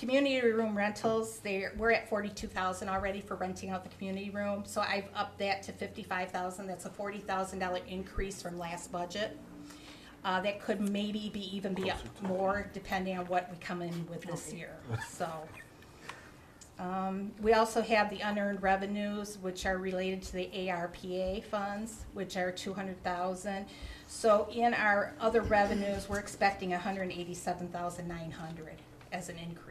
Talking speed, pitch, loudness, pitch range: 145 wpm, 195 Hz, -34 LUFS, 185-205 Hz